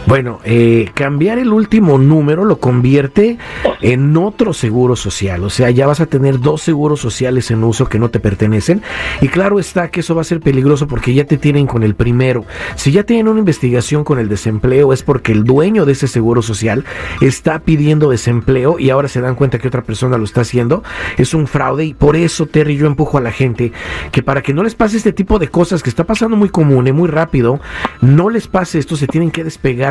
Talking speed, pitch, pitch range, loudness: 225 wpm, 140 Hz, 125-165 Hz, -13 LUFS